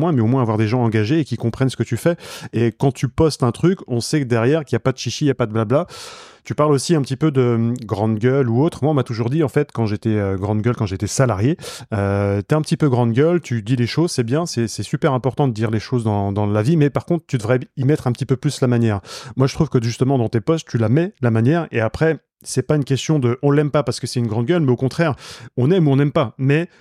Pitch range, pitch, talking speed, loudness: 115-150 Hz, 130 Hz, 310 wpm, -19 LUFS